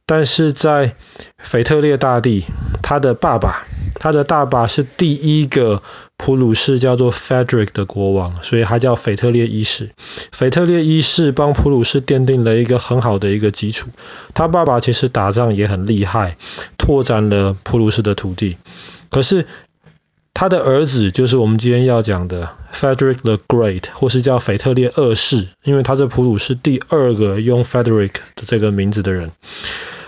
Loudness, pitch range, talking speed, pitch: -15 LUFS, 105-135 Hz, 295 characters per minute, 120 Hz